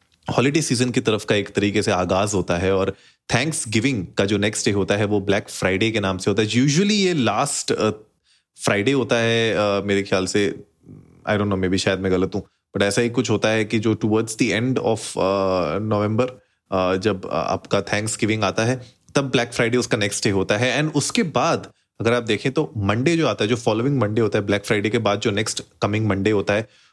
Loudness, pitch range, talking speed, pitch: -21 LUFS, 100-120 Hz, 225 wpm, 105 Hz